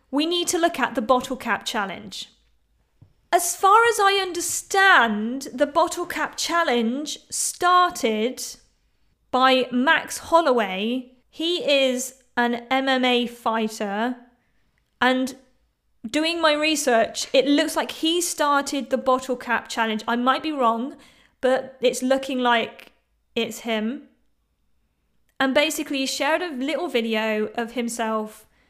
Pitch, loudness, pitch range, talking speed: 260 Hz, -22 LUFS, 240-310 Hz, 125 wpm